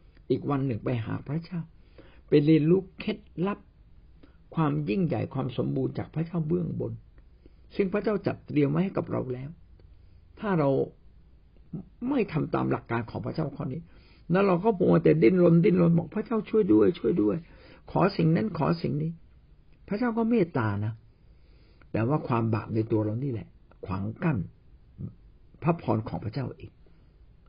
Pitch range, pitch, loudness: 110-175 Hz, 145 Hz, -27 LUFS